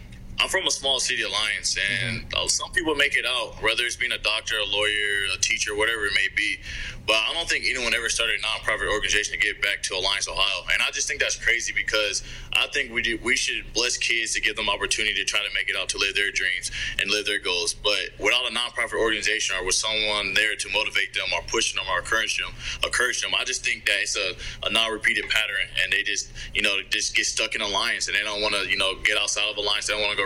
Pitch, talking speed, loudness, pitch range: 110 Hz, 255 wpm, -23 LUFS, 105-135 Hz